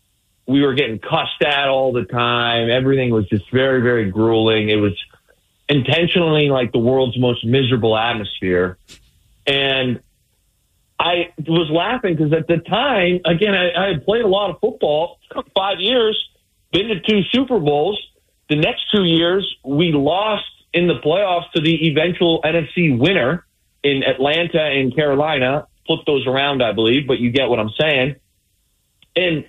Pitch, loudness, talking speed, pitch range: 145 Hz, -17 LUFS, 155 wpm, 125-170 Hz